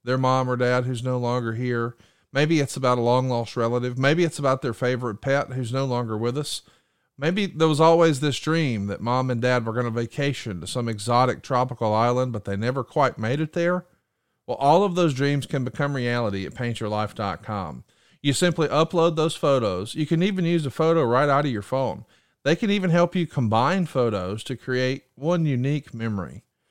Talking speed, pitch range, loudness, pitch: 200 wpm, 120-150 Hz, -23 LUFS, 130 Hz